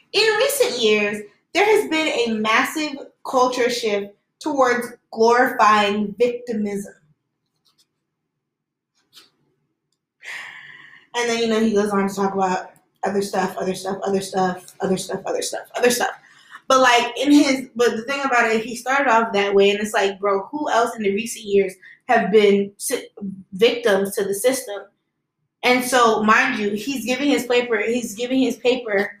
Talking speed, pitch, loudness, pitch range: 160 wpm, 225 Hz, -19 LUFS, 200-250 Hz